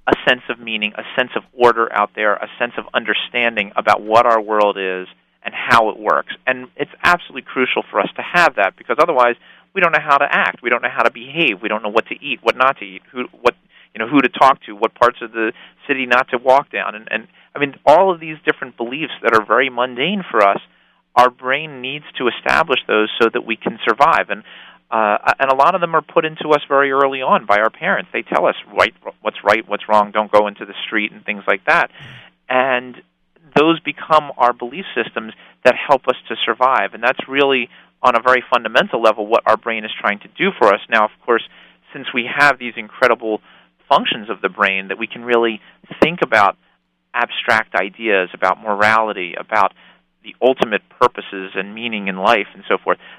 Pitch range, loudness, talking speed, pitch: 105-135 Hz, -16 LUFS, 220 wpm, 120 Hz